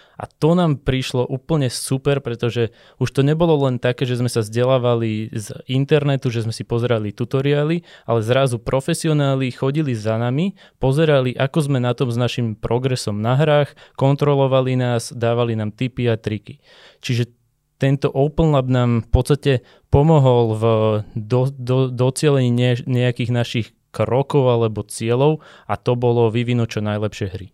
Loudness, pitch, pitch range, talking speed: -19 LUFS, 125 Hz, 120-140 Hz, 155 wpm